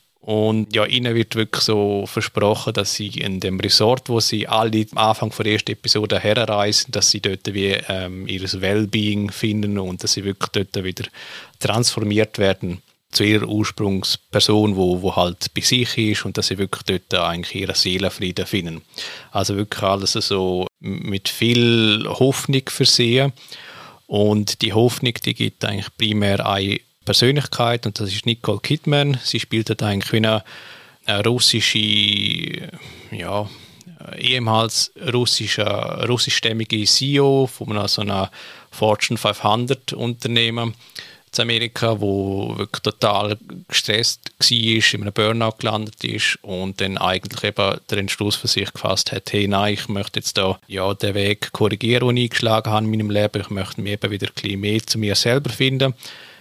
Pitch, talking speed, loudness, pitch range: 105 Hz, 155 wpm, -19 LUFS, 100-115 Hz